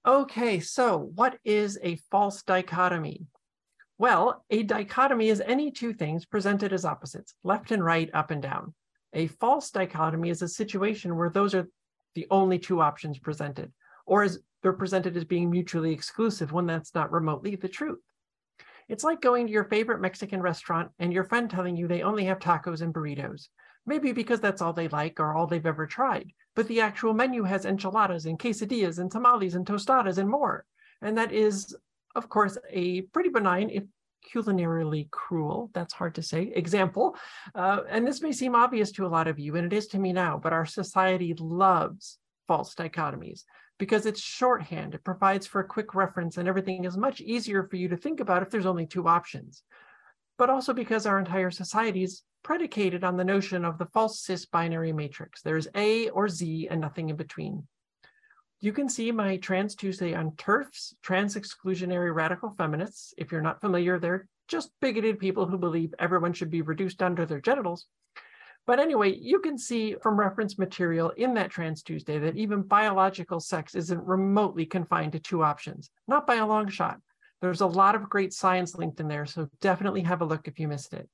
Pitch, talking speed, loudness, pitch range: 190 Hz, 190 wpm, -28 LUFS, 170-215 Hz